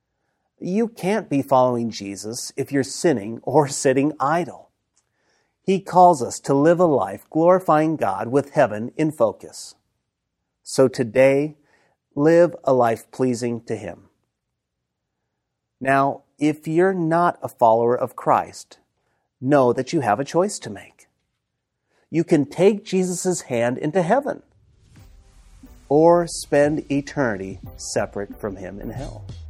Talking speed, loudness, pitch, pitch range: 130 wpm, -20 LUFS, 135 Hz, 110-165 Hz